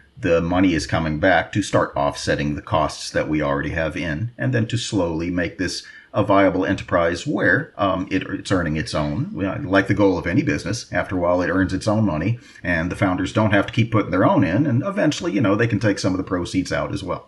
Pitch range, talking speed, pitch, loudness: 85-105 Hz, 245 wpm, 95 Hz, -21 LUFS